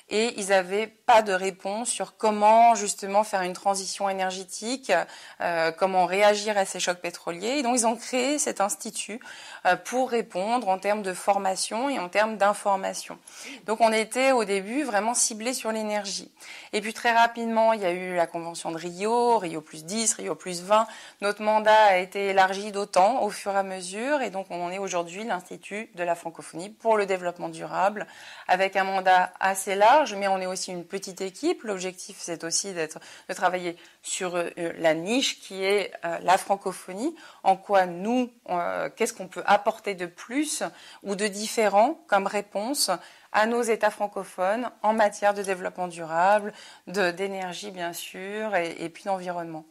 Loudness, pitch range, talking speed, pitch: -25 LUFS, 185-220 Hz, 175 wpm, 200 Hz